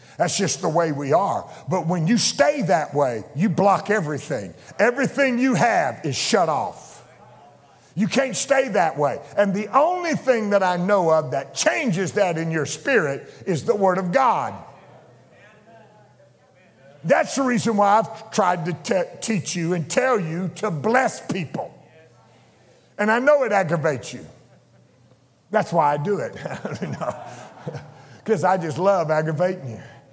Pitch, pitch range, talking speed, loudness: 185 Hz, 155-215 Hz, 155 wpm, -21 LUFS